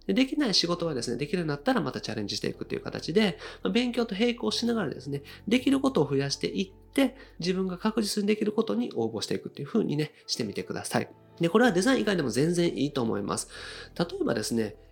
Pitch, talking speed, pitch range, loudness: 180 Hz, 495 characters per minute, 135-230 Hz, -28 LUFS